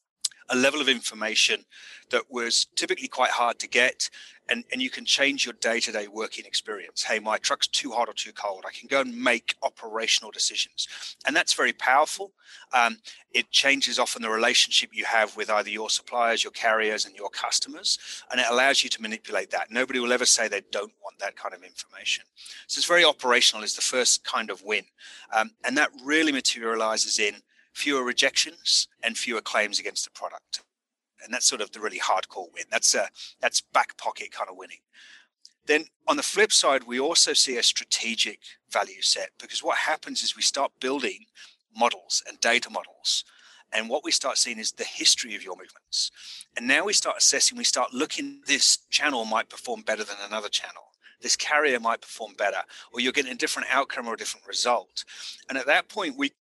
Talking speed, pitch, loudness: 200 wpm, 135 Hz, -24 LUFS